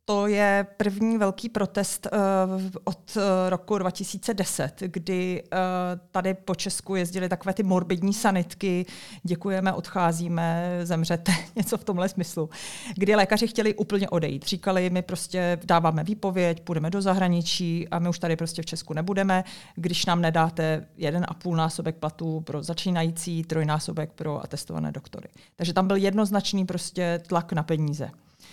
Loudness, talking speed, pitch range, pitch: -26 LUFS, 145 wpm, 165-195 Hz, 180 Hz